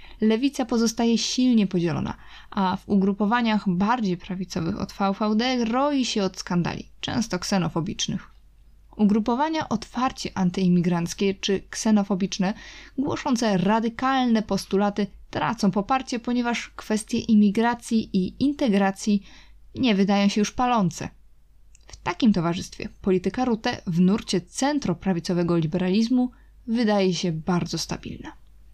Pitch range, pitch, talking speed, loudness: 185-235 Hz, 205 Hz, 105 wpm, -24 LUFS